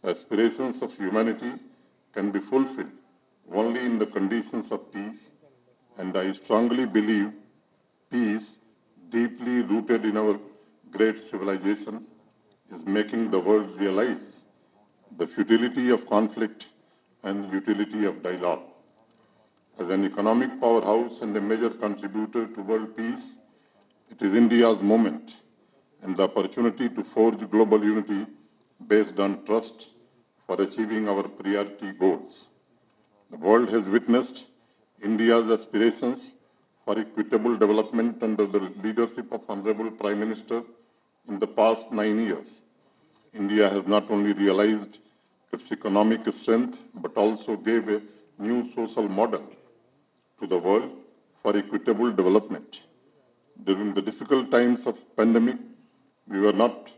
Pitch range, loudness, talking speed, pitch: 105-115 Hz, -25 LUFS, 125 wpm, 110 Hz